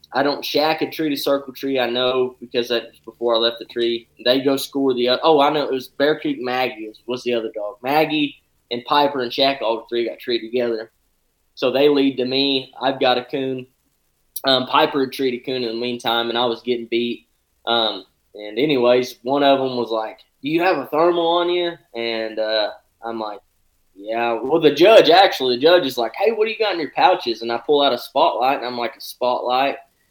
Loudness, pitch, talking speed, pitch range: -19 LUFS, 125 Hz, 225 wpm, 115-140 Hz